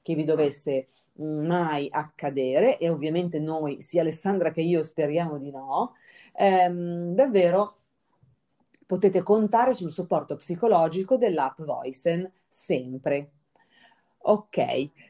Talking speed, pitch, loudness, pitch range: 105 wpm, 165 Hz, -25 LUFS, 150-185 Hz